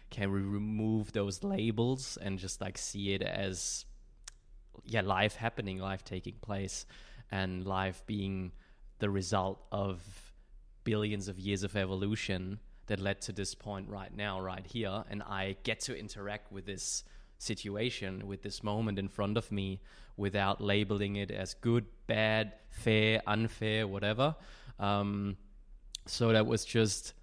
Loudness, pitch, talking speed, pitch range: -35 LUFS, 100 Hz, 145 wpm, 95-110 Hz